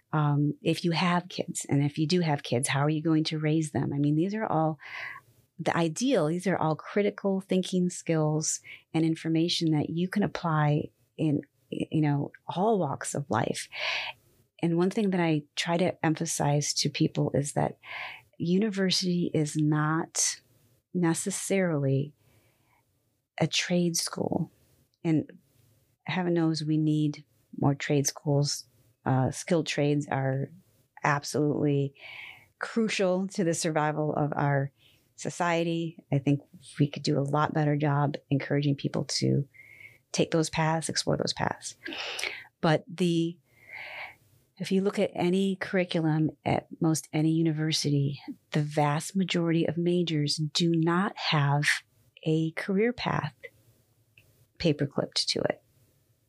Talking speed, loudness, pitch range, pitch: 135 wpm, -28 LUFS, 140-170 Hz, 155 Hz